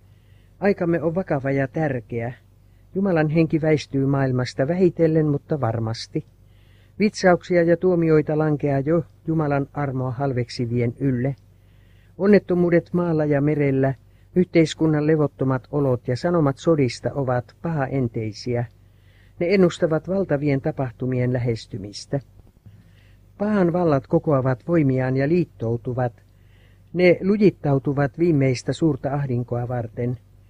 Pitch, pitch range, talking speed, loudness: 135 Hz, 115-160 Hz, 100 wpm, -22 LUFS